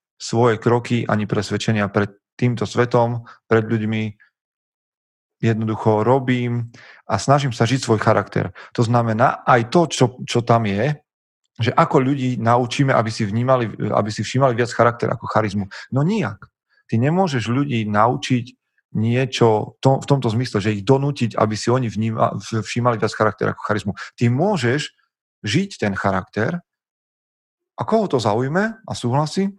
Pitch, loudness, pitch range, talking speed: 120 Hz, -20 LUFS, 110-130 Hz, 150 wpm